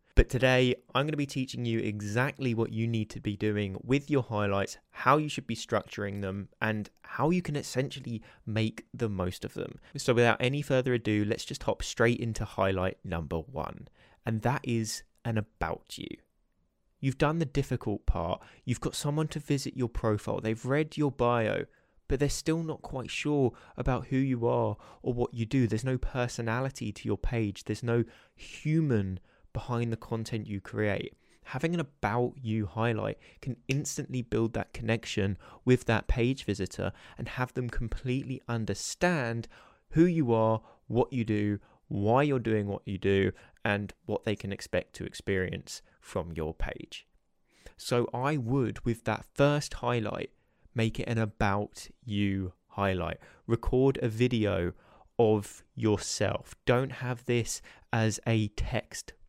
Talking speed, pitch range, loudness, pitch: 165 wpm, 105-130 Hz, -31 LUFS, 115 Hz